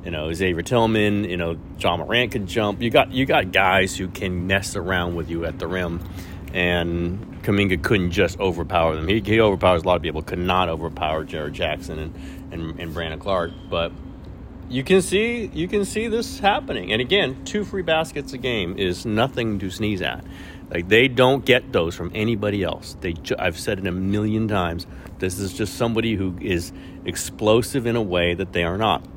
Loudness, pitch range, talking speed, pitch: -22 LUFS, 85-110 Hz, 200 wpm, 95 Hz